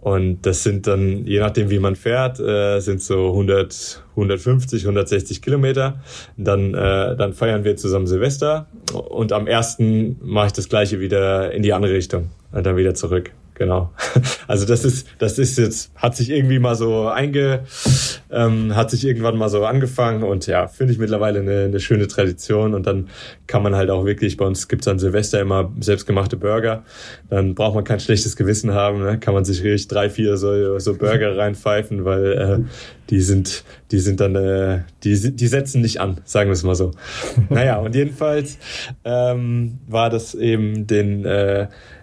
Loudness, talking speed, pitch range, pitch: -19 LUFS, 185 wpm, 100-120 Hz, 105 Hz